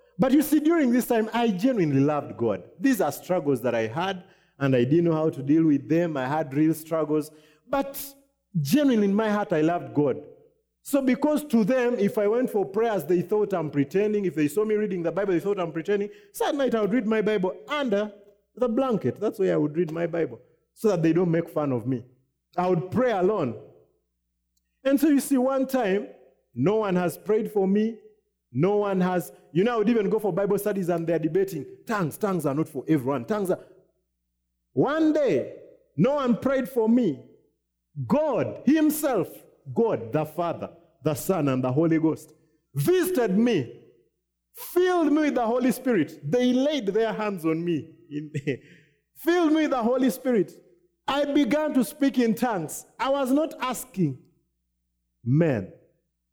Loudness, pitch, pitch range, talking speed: -25 LUFS, 200 Hz, 155-250 Hz, 190 wpm